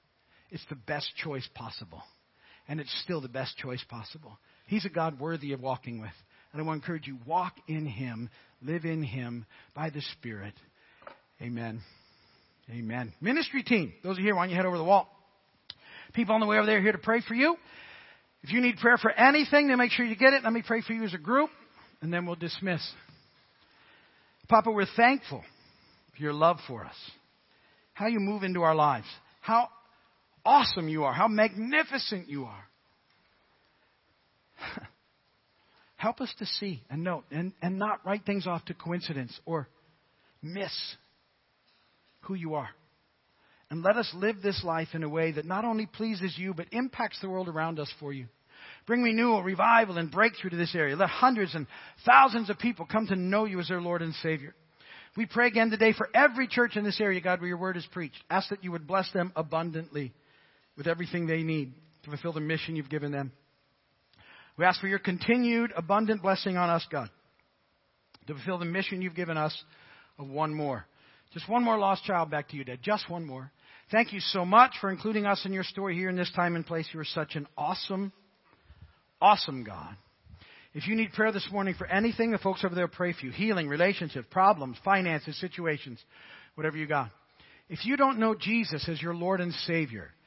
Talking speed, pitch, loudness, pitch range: 195 wpm, 175 Hz, -28 LUFS, 150-210 Hz